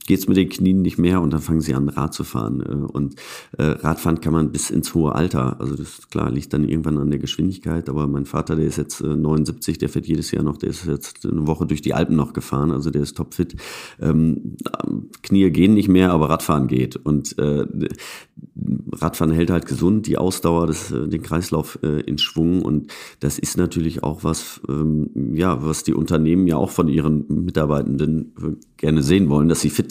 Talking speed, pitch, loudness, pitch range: 195 wpm, 80 Hz, -20 LUFS, 75-85 Hz